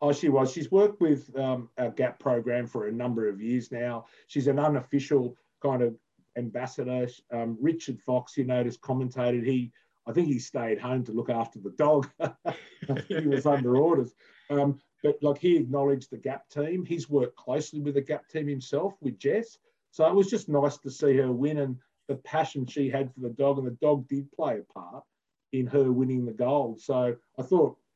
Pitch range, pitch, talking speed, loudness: 125-145 Hz, 135 Hz, 200 wpm, -28 LUFS